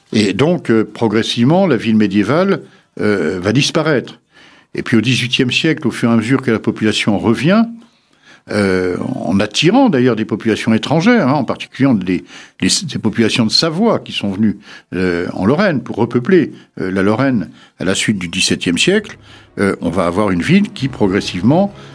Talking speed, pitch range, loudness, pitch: 180 wpm, 105-135 Hz, -14 LUFS, 115 Hz